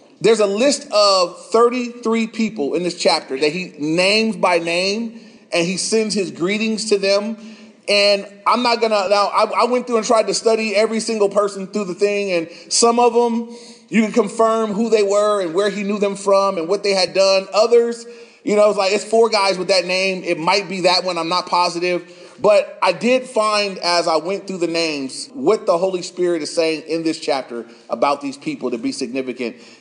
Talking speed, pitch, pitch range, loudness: 210 wpm, 205 Hz, 180-225 Hz, -17 LUFS